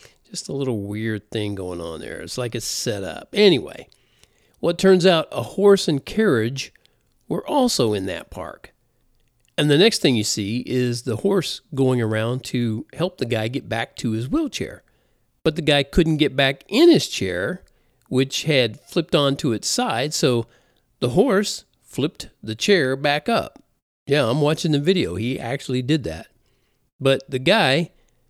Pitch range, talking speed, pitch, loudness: 120-165 Hz, 175 wpm, 130 Hz, -21 LUFS